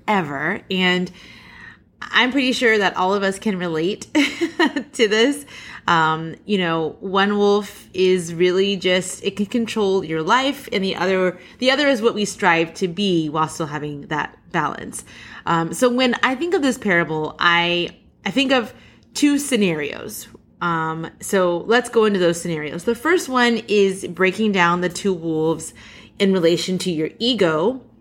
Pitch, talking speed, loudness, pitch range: 190 Hz, 165 wpm, -19 LUFS, 170-230 Hz